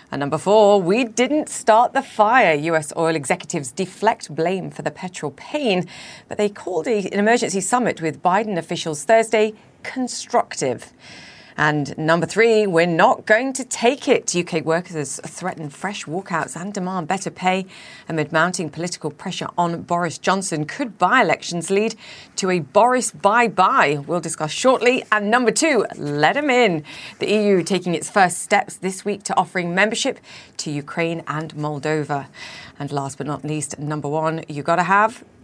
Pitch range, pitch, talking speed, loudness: 160-215 Hz, 185 Hz, 160 wpm, -20 LUFS